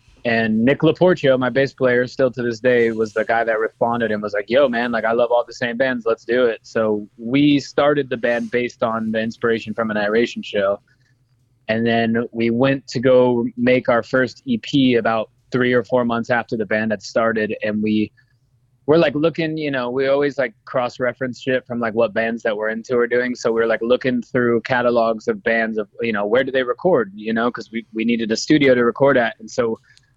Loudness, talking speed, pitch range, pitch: -19 LUFS, 225 wpm, 115-130 Hz, 120 Hz